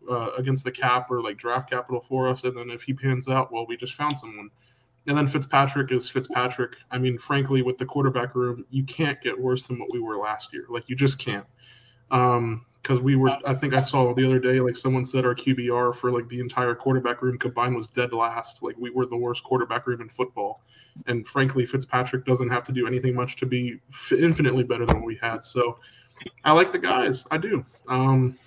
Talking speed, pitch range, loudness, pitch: 225 wpm, 120-130 Hz, -25 LUFS, 125 Hz